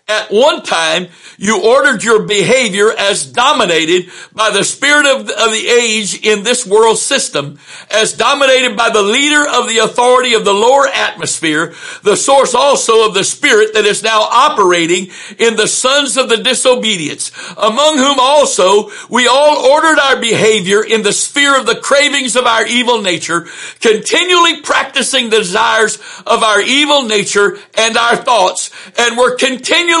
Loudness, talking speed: -10 LUFS, 160 wpm